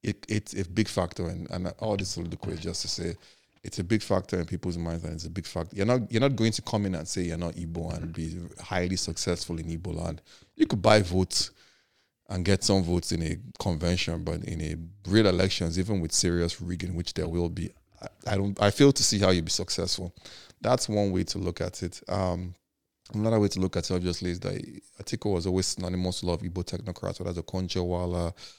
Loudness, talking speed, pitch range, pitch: -28 LUFS, 235 wpm, 85-100 Hz, 90 Hz